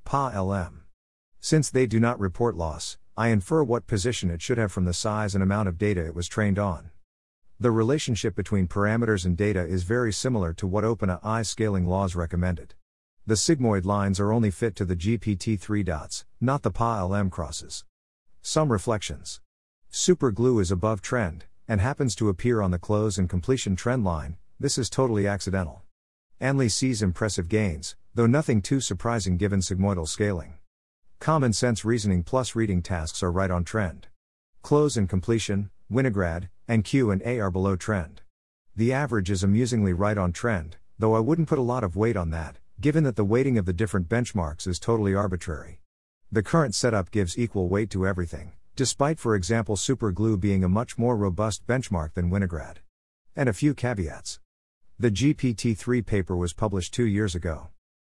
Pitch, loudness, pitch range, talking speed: 100 Hz, -26 LUFS, 90-115 Hz, 175 wpm